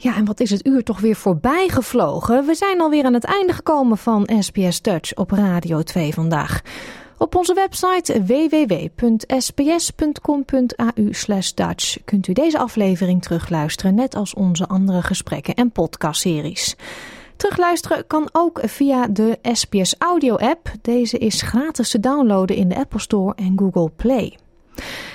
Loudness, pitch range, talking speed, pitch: -18 LUFS, 190-275 Hz, 145 wpm, 230 Hz